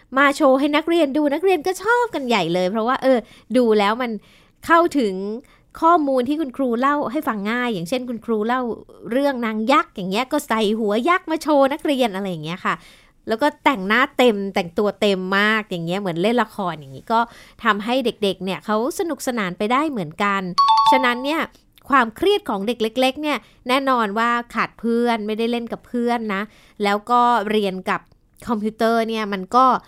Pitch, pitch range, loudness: 235 Hz, 210-275 Hz, -20 LUFS